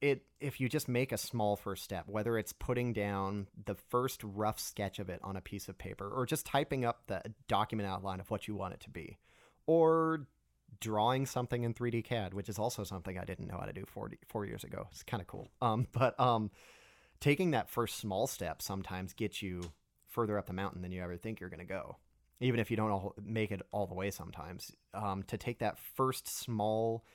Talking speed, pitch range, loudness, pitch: 225 wpm, 95-120 Hz, -37 LUFS, 110 Hz